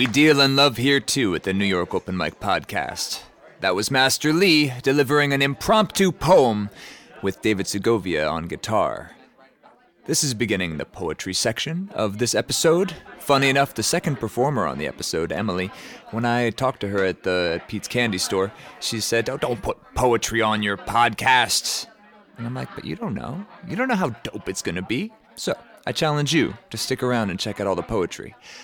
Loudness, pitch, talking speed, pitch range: -22 LUFS, 120 Hz, 195 wpm, 100-140 Hz